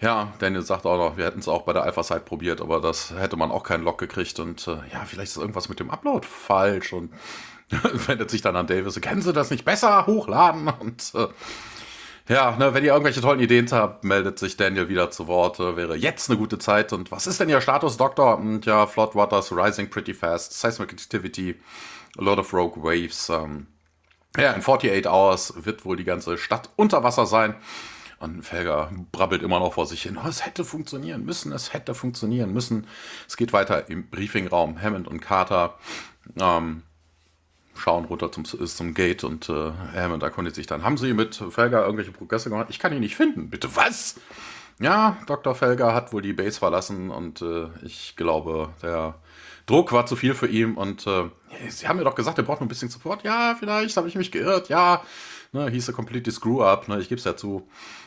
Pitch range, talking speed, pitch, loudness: 85-125 Hz, 210 wpm, 105 Hz, -23 LUFS